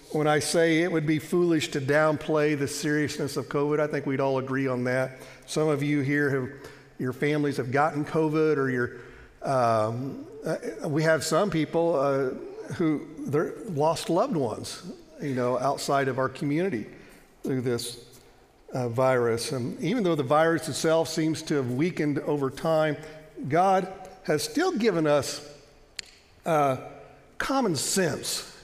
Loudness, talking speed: -26 LUFS, 150 wpm